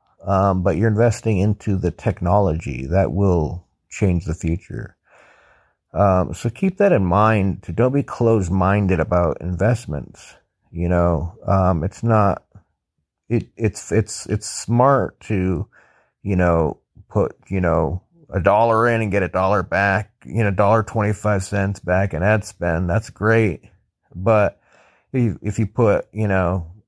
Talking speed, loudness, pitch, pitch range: 150 wpm, -20 LUFS, 100 Hz, 90-110 Hz